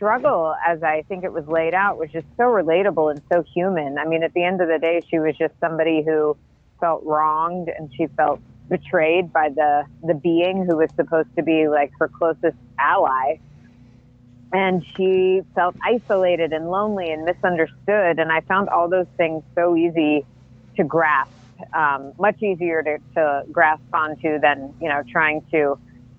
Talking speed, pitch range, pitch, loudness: 175 wpm, 150-175 Hz, 160 Hz, -20 LUFS